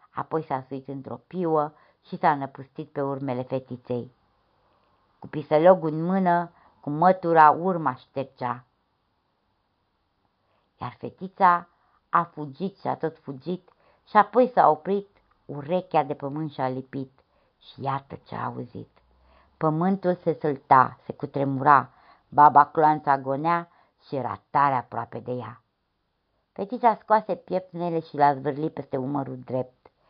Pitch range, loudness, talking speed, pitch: 130-170 Hz, -24 LUFS, 130 wpm, 145 Hz